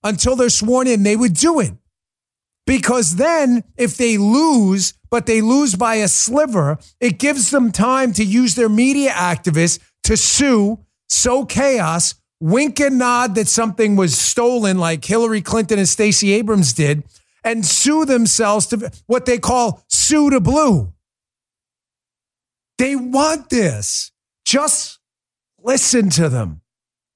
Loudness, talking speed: -15 LUFS, 140 wpm